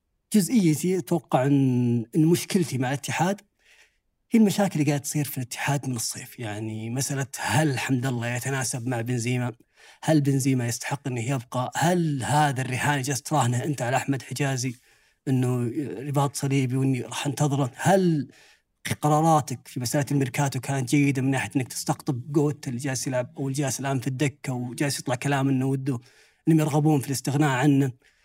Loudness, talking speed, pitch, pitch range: -25 LUFS, 155 wpm, 140 Hz, 130-150 Hz